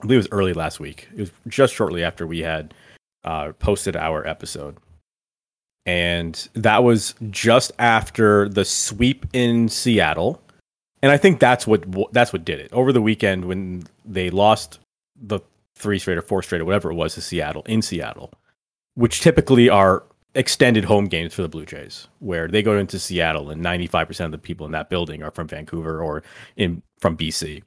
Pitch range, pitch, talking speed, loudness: 80-110 Hz, 95 Hz, 190 wpm, -20 LUFS